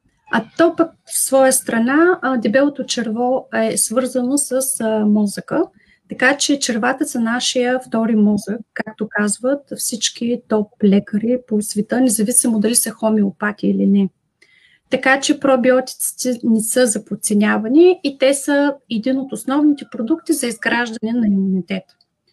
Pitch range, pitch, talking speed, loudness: 215-270 Hz, 245 Hz, 130 wpm, -17 LUFS